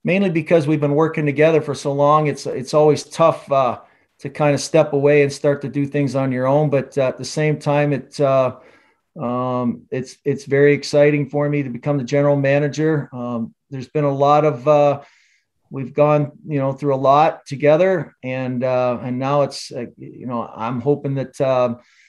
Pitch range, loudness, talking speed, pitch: 130-150 Hz, -18 LUFS, 200 wpm, 140 Hz